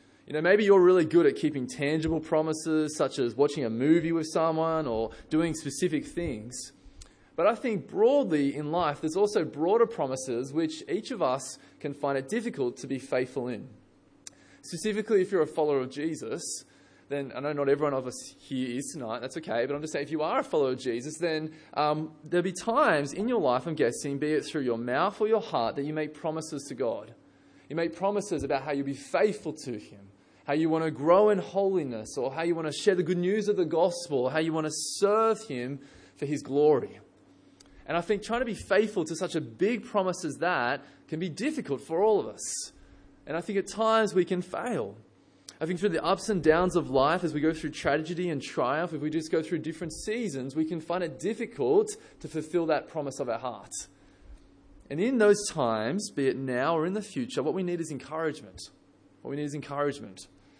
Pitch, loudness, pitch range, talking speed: 160 Hz, -29 LUFS, 140-185 Hz, 220 wpm